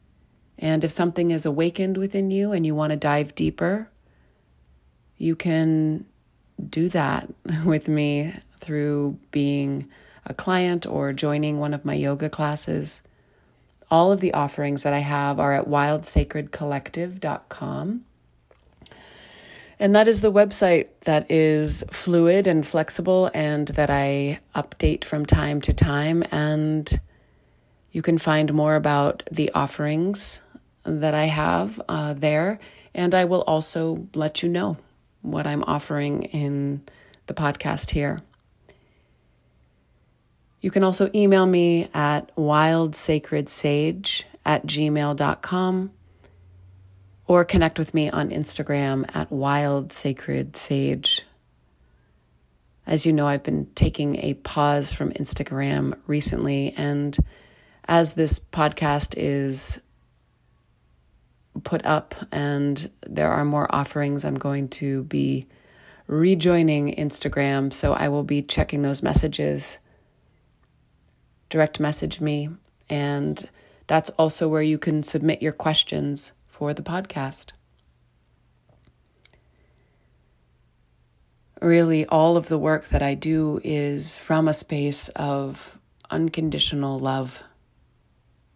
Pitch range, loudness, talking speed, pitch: 140-160 Hz, -22 LUFS, 115 wpm, 150 Hz